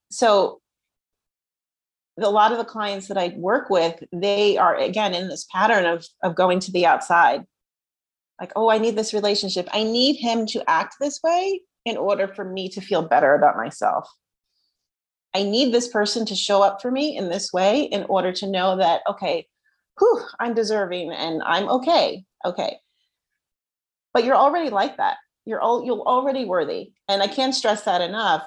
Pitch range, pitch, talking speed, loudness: 190-255 Hz, 210 Hz, 180 wpm, -21 LUFS